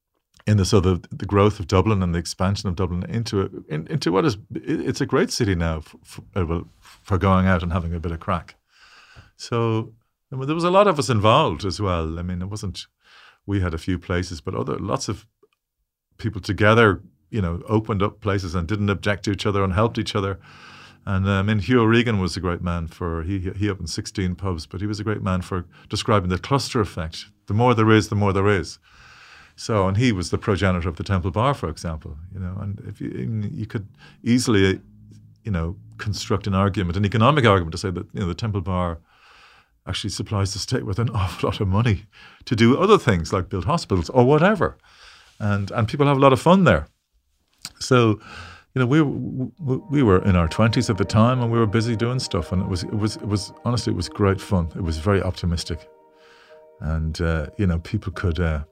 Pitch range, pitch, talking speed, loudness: 90-110 Hz, 100 Hz, 220 wpm, -22 LUFS